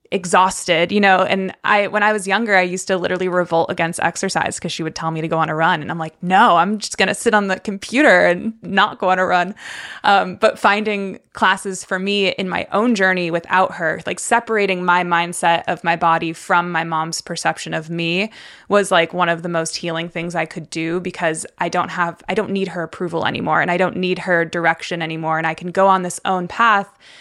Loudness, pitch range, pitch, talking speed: -18 LUFS, 170-195 Hz, 180 Hz, 230 wpm